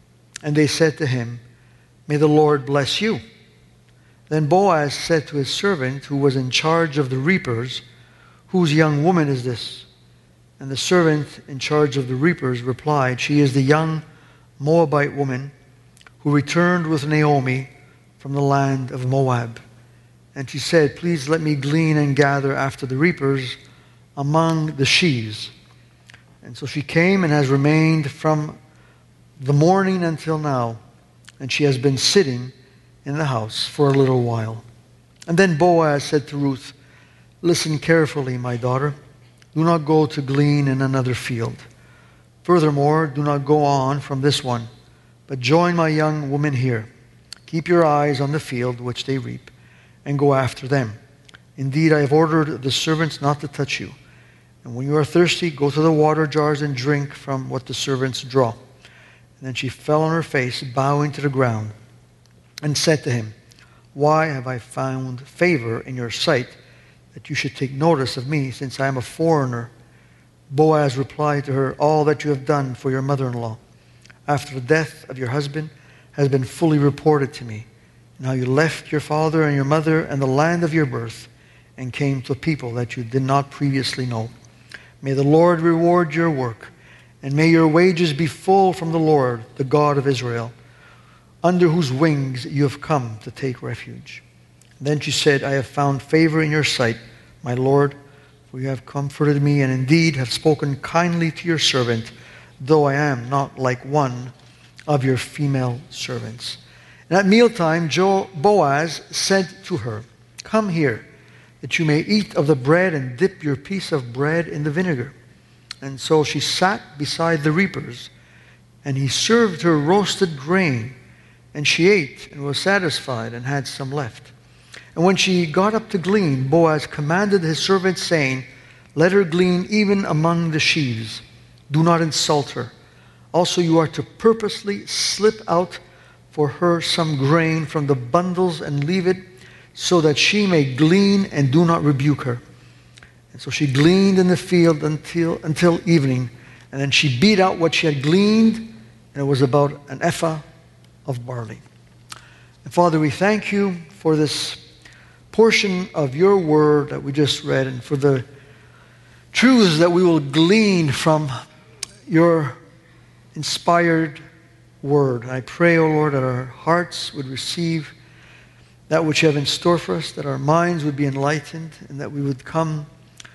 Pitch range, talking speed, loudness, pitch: 130-160 Hz, 170 wpm, -19 LUFS, 145 Hz